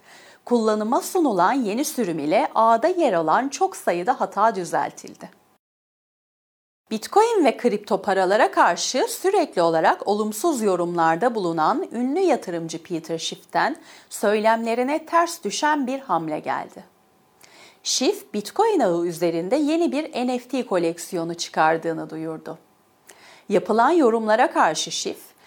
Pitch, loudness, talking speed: 220 Hz, -22 LUFS, 110 wpm